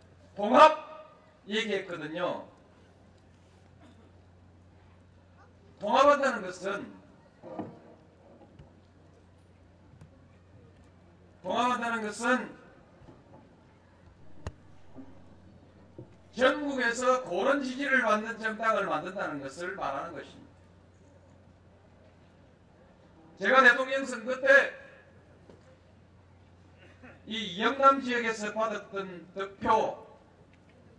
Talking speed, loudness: 135 characters per minute, -27 LUFS